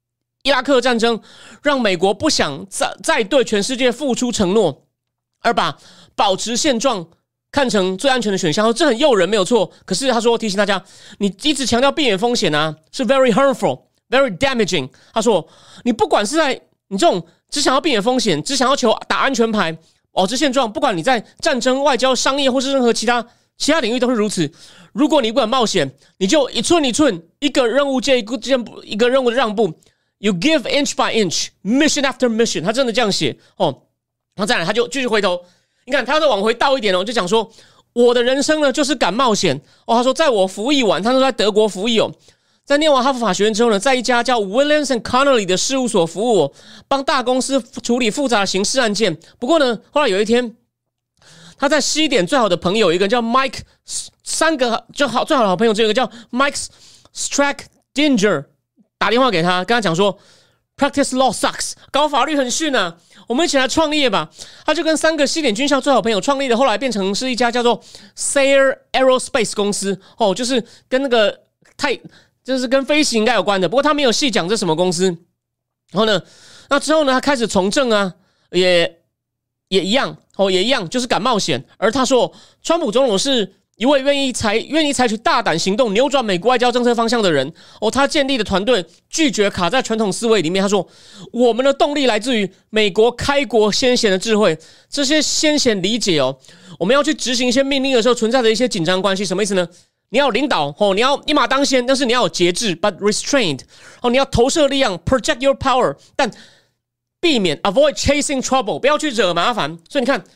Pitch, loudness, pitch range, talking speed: 240 Hz, -17 LUFS, 200-275 Hz, 370 characters per minute